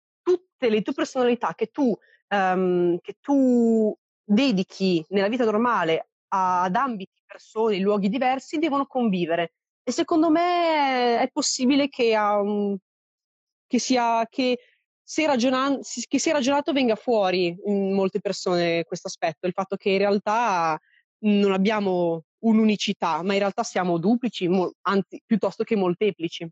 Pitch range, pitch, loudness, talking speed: 190-255 Hz, 215 Hz, -23 LUFS, 140 wpm